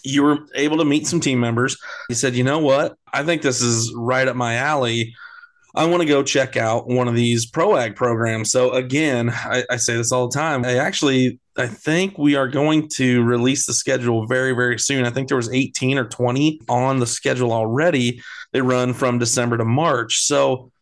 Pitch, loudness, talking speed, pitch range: 130 Hz, -19 LUFS, 215 wpm, 120-145 Hz